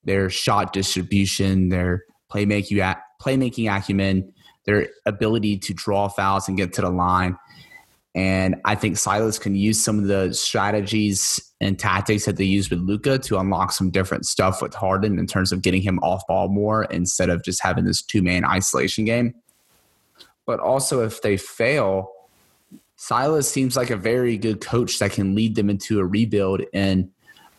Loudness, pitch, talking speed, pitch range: -21 LUFS, 100 Hz, 170 wpm, 95-110 Hz